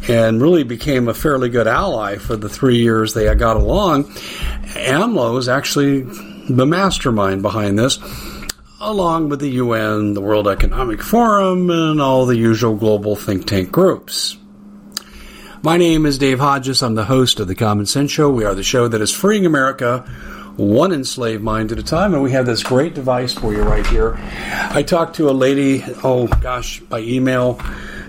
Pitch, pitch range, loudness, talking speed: 125 Hz, 110-145 Hz, -16 LUFS, 175 wpm